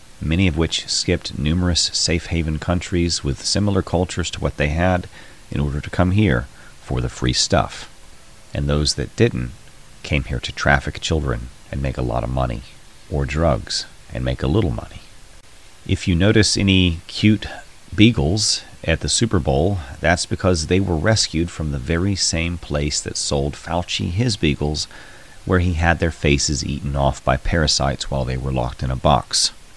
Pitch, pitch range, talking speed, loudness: 85 Hz, 70-95 Hz, 175 wpm, -20 LUFS